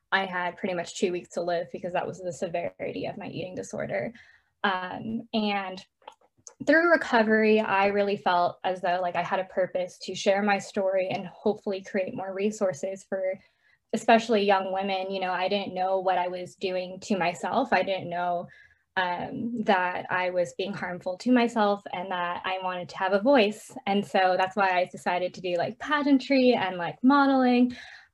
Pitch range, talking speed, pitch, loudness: 180-210 Hz, 185 wpm, 190 Hz, -27 LUFS